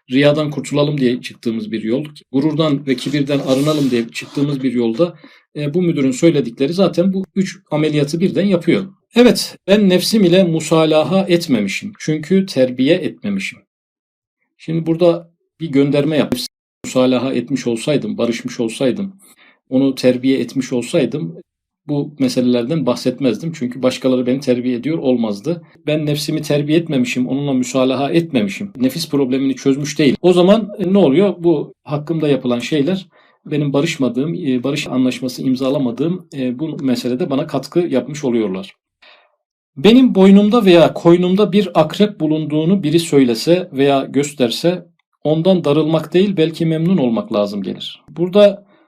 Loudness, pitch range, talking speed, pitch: -16 LUFS, 130-175 Hz, 130 wpm, 150 Hz